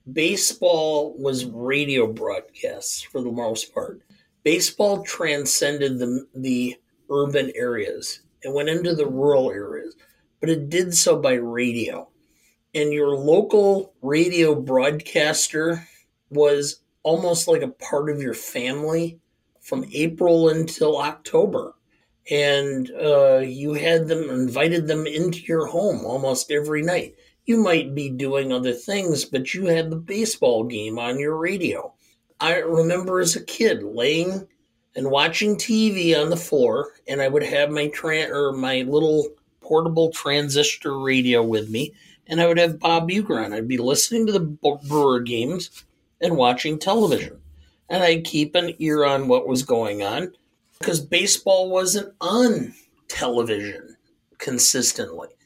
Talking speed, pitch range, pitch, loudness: 140 wpm, 135-175 Hz, 155 Hz, -21 LUFS